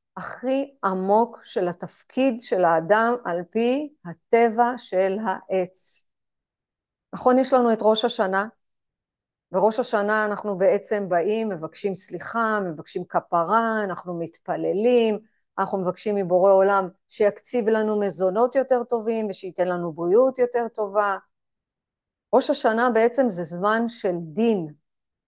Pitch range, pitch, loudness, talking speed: 185-230 Hz, 210 Hz, -23 LUFS, 115 wpm